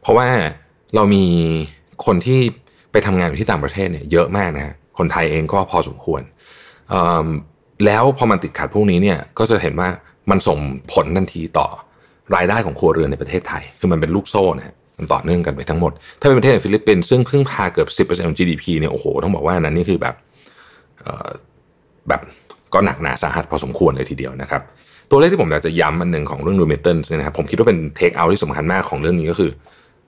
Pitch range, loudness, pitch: 75-100 Hz, -17 LUFS, 85 Hz